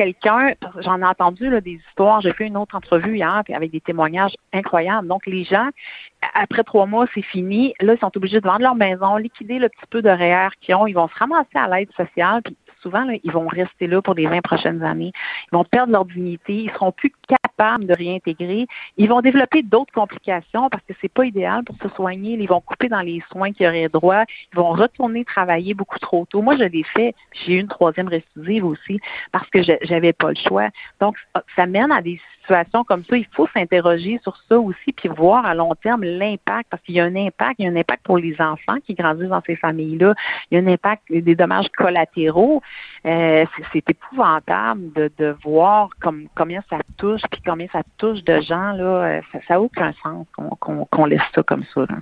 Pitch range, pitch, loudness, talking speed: 170-215 Hz, 190 Hz, -18 LUFS, 225 wpm